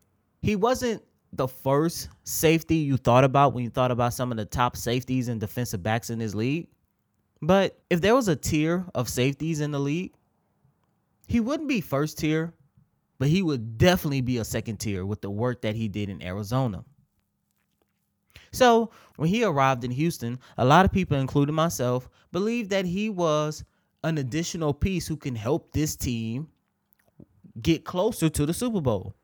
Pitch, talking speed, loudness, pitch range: 140 Hz, 175 wpm, -25 LUFS, 120-165 Hz